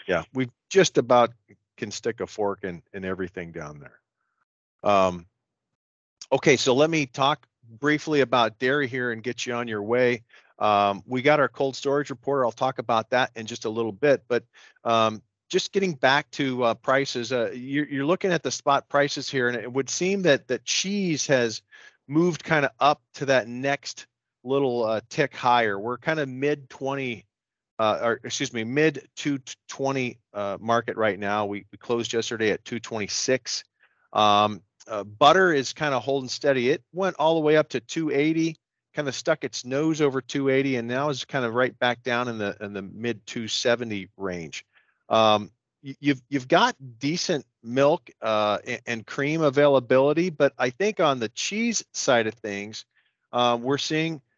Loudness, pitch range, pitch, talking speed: -24 LUFS, 115-145 Hz, 130 Hz, 180 wpm